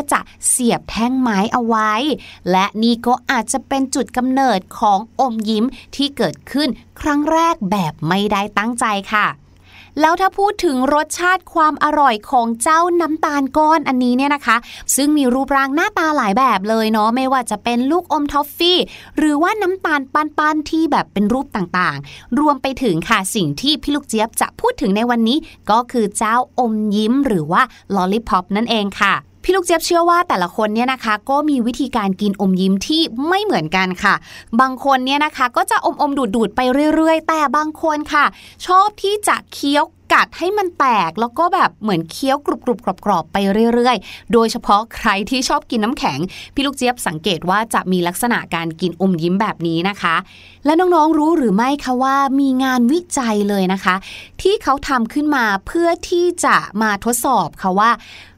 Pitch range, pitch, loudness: 210-300 Hz, 255 Hz, -16 LUFS